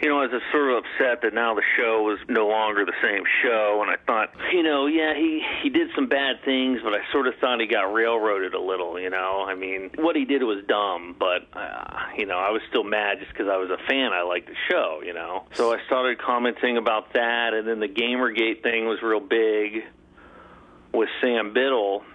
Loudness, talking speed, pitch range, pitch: -23 LUFS, 235 wpm, 105-135 Hz, 115 Hz